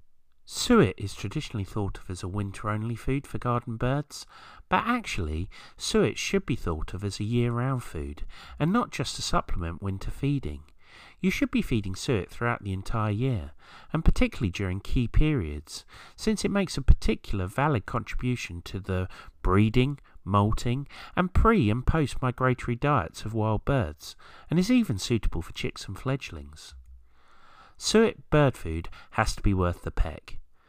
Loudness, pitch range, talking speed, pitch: -28 LUFS, 90-135 Hz, 160 wpm, 110 Hz